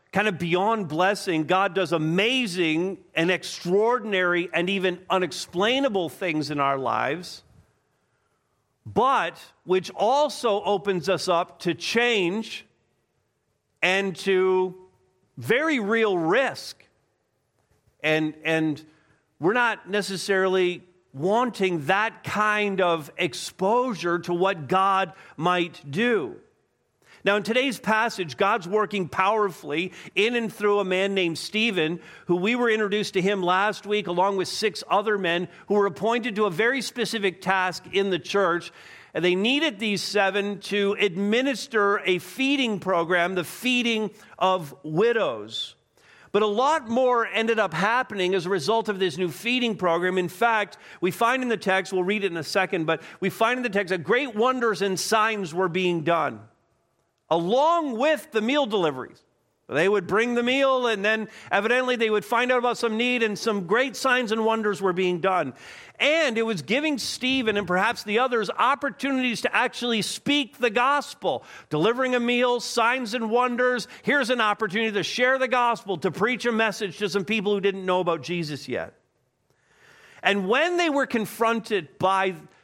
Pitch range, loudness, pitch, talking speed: 180-230 Hz, -24 LUFS, 200 Hz, 155 wpm